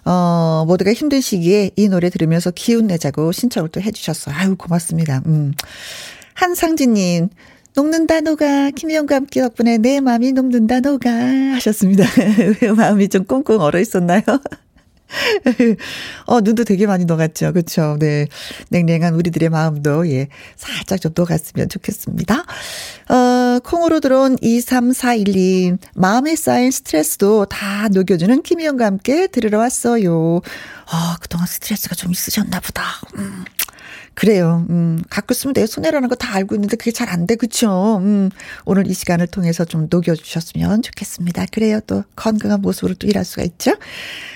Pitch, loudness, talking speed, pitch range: 205 Hz, -16 LUFS, 320 characters per minute, 175-245 Hz